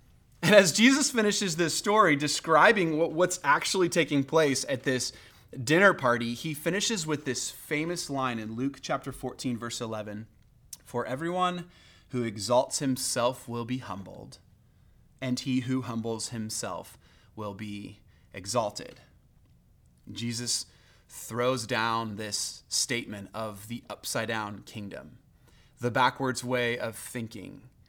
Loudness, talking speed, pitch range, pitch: -28 LUFS, 125 wpm, 110-150 Hz, 125 Hz